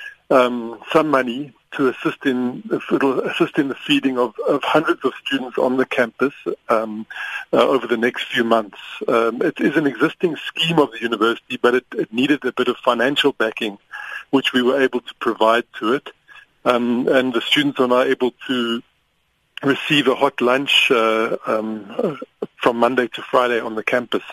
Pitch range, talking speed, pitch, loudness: 115-130 Hz, 180 wpm, 125 Hz, -19 LUFS